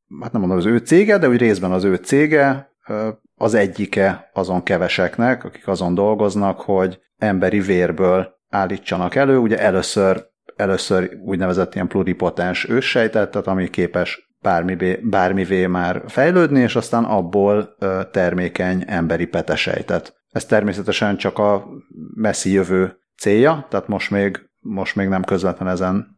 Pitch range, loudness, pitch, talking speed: 90-105 Hz, -18 LUFS, 95 Hz, 135 wpm